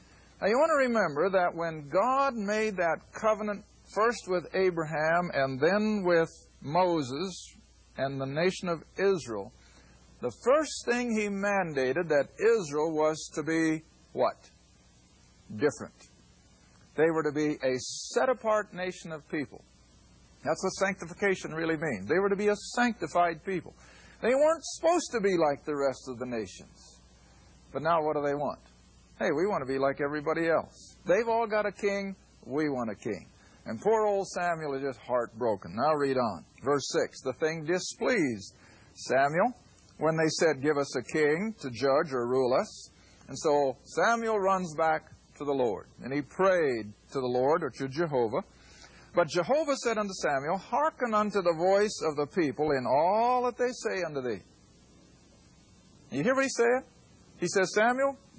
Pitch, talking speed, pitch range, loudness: 165 Hz, 170 wpm, 135-205 Hz, -29 LUFS